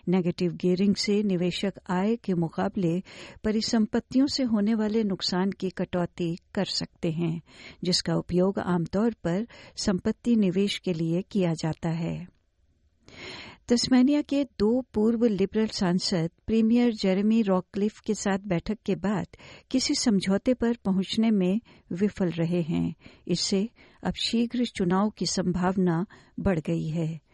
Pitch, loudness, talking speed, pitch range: 190 Hz, -27 LUFS, 130 wpm, 175-220 Hz